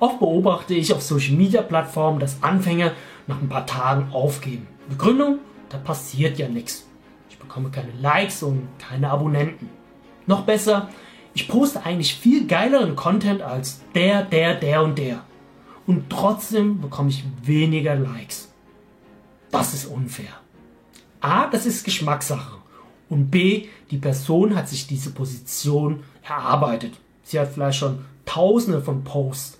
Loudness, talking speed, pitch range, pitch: -21 LUFS, 140 wpm, 135-195 Hz, 150 Hz